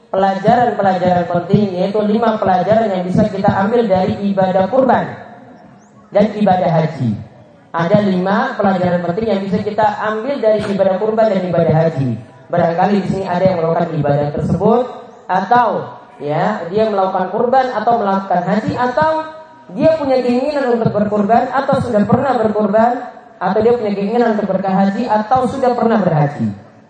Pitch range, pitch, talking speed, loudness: 185-235 Hz, 210 Hz, 145 wpm, -15 LUFS